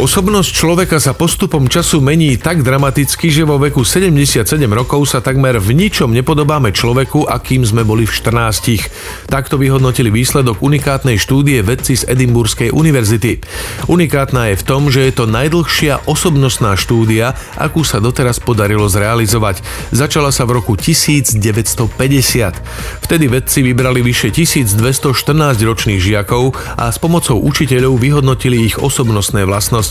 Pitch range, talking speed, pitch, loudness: 115-145 Hz, 135 wpm, 130 Hz, -12 LUFS